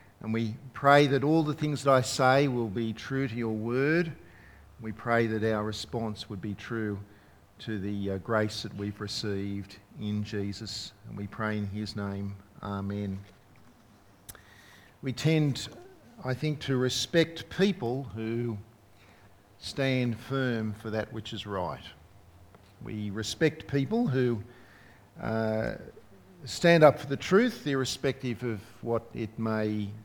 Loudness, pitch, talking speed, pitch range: -29 LUFS, 110 Hz, 140 wpm, 100-130 Hz